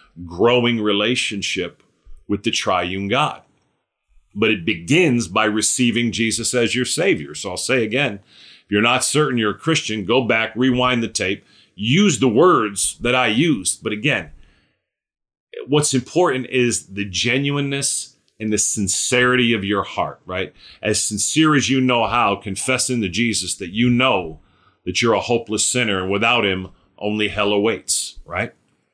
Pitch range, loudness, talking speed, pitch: 100-125 Hz, -18 LUFS, 155 wpm, 115 Hz